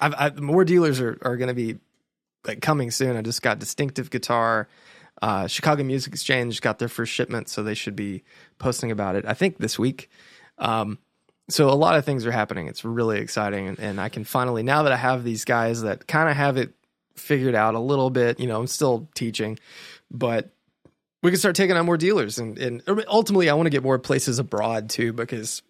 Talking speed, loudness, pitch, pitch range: 215 wpm, -23 LUFS, 125 Hz, 110-145 Hz